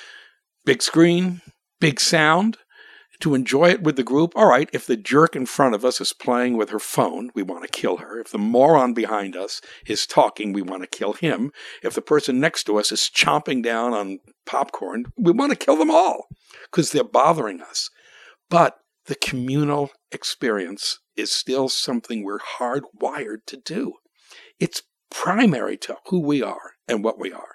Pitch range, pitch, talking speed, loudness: 115-175 Hz, 140 Hz, 180 wpm, -21 LUFS